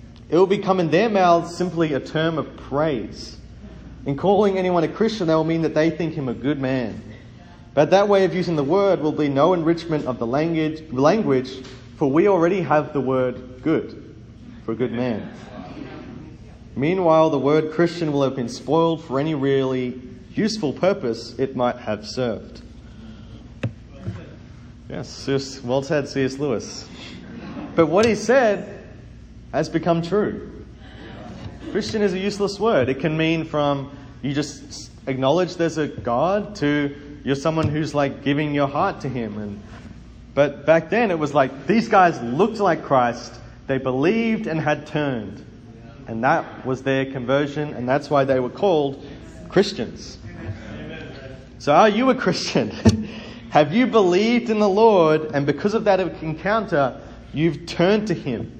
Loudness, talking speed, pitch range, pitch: -21 LUFS, 160 wpm, 130-175 Hz, 150 Hz